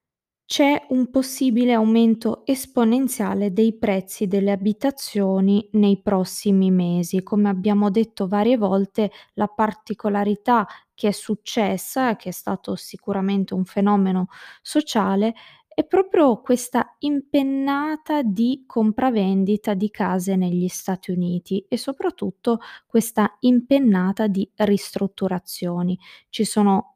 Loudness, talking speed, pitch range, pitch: -21 LUFS, 105 wpm, 195-245 Hz, 210 Hz